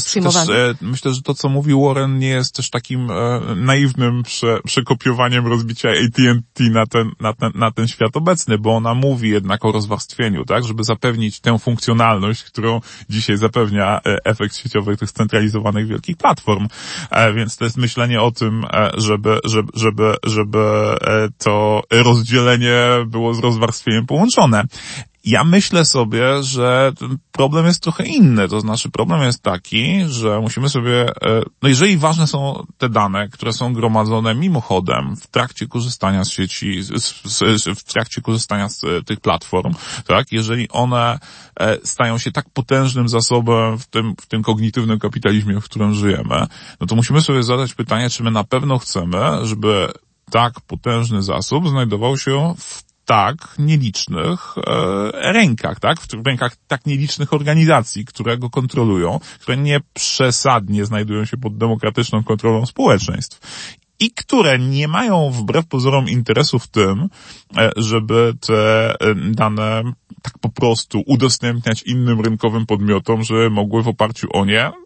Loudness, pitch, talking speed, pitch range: -16 LUFS, 115 Hz, 150 wpm, 110-130 Hz